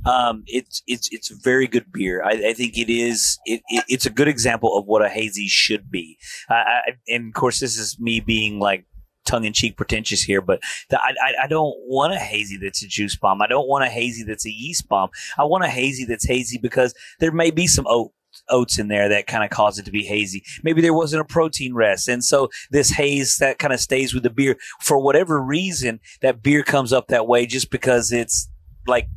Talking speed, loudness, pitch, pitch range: 230 wpm, -19 LUFS, 120 Hz, 110-135 Hz